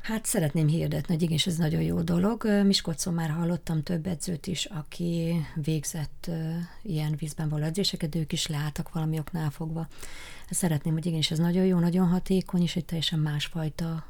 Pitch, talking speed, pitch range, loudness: 165 Hz, 165 wpm, 155-175 Hz, -28 LUFS